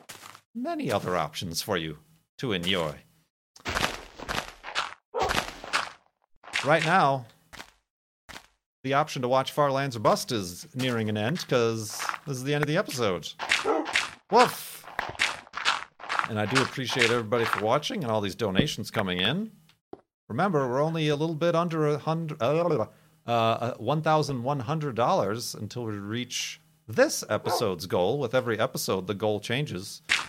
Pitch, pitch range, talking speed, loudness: 135 Hz, 115-155 Hz, 125 wpm, -27 LUFS